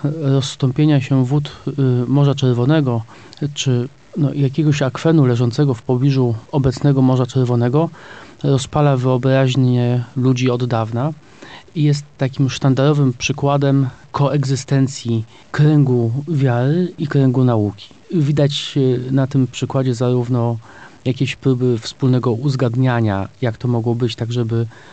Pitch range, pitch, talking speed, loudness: 125-140 Hz, 130 Hz, 110 wpm, -17 LUFS